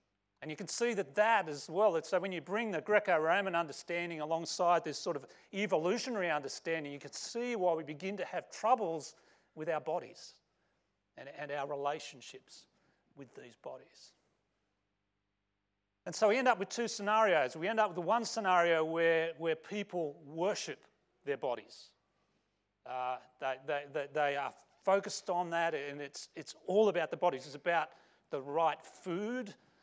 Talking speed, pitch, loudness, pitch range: 165 wpm, 165 Hz, -35 LUFS, 145-200 Hz